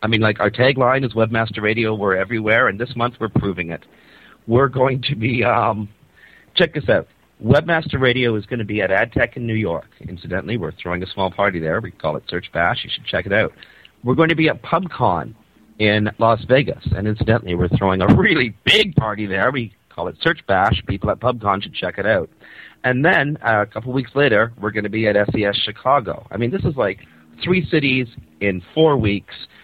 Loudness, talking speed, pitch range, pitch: -18 LUFS, 215 wpm, 100-130 Hz, 110 Hz